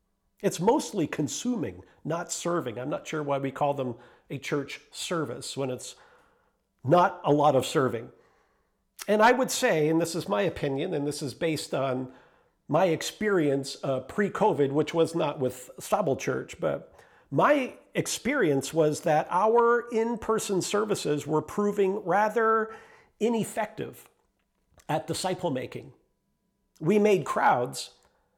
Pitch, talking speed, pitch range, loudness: 165 Hz, 135 wpm, 145-205 Hz, -27 LUFS